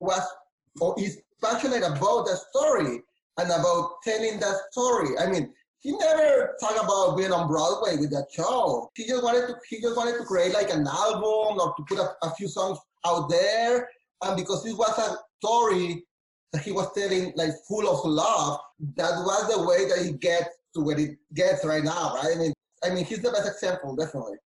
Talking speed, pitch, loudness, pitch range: 205 wpm, 190 Hz, -26 LUFS, 170-220 Hz